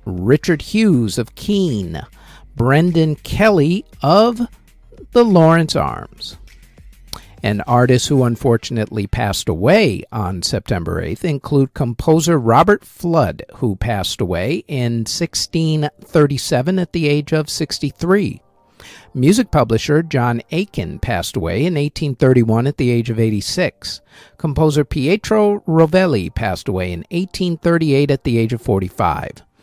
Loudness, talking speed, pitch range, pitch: -16 LUFS, 115 wpm, 115-170 Hz, 145 Hz